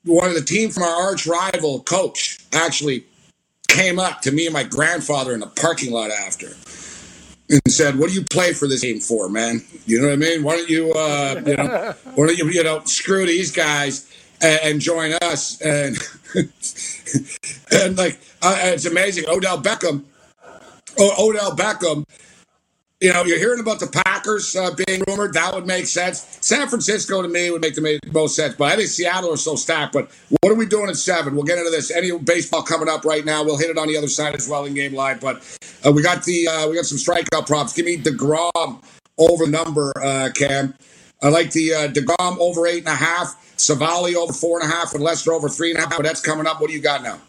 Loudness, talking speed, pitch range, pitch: -18 LUFS, 225 wpm, 145-175 Hz, 165 Hz